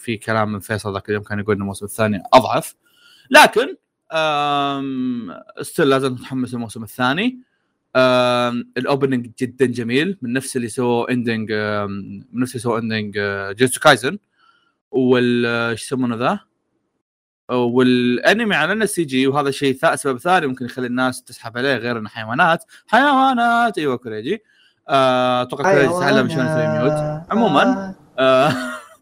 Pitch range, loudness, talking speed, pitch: 115-140 Hz, -18 LUFS, 130 wpm, 125 Hz